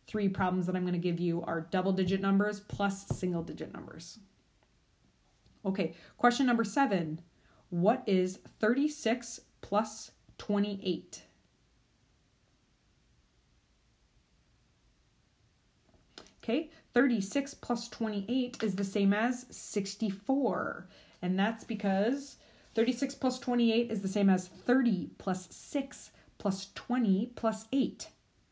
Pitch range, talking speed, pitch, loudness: 190-245 Hz, 105 wpm, 205 Hz, -32 LUFS